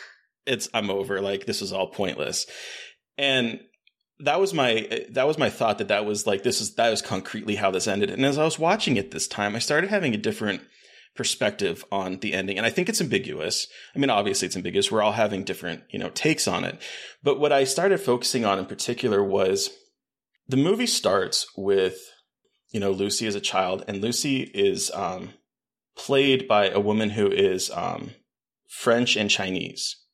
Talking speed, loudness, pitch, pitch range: 195 wpm, -24 LUFS, 115 Hz, 100-140 Hz